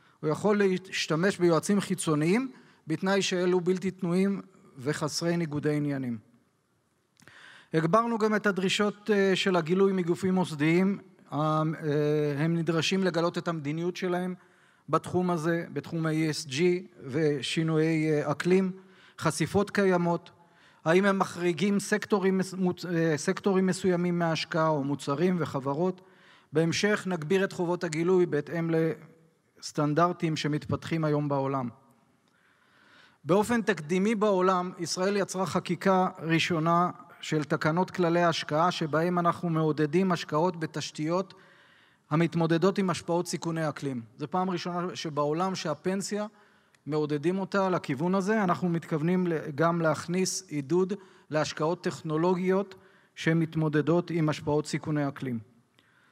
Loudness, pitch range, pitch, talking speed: -28 LUFS, 155-185 Hz, 170 Hz, 105 wpm